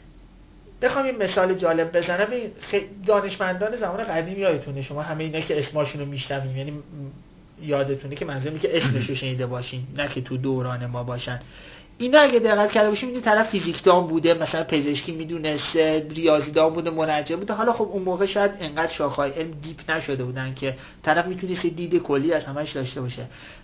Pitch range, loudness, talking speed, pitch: 140-190 Hz, -23 LUFS, 175 wpm, 160 Hz